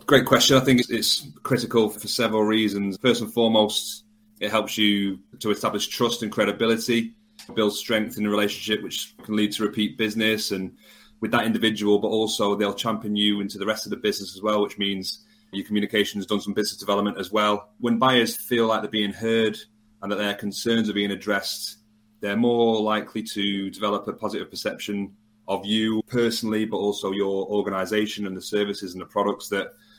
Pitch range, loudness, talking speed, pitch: 100-110 Hz, -24 LUFS, 190 wpm, 105 Hz